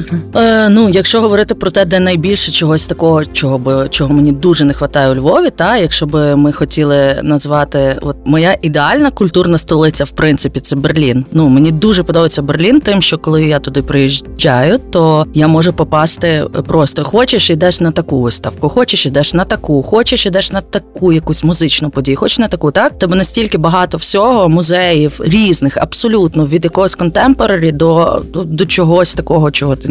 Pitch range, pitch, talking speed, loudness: 145-190 Hz, 165 Hz, 175 wpm, -9 LUFS